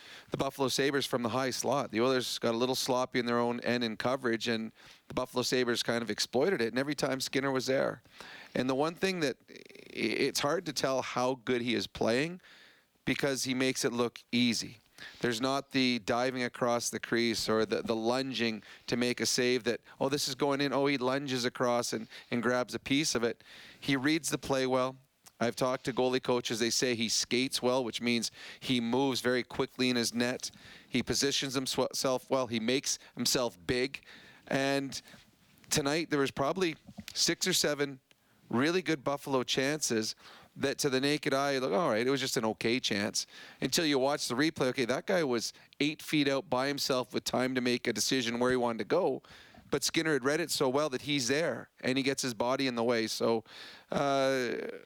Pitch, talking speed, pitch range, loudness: 130 Hz, 205 wpm, 120-140 Hz, -31 LUFS